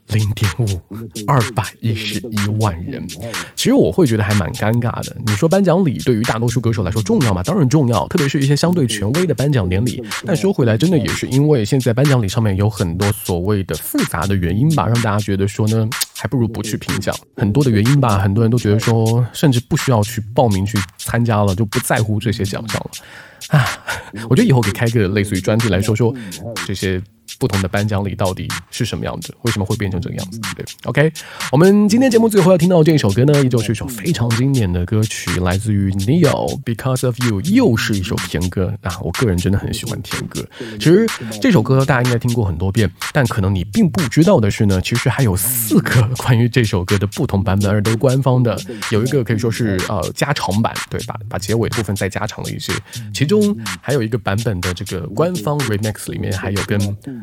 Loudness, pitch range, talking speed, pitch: -17 LUFS, 100-130 Hz, 355 characters per minute, 115 Hz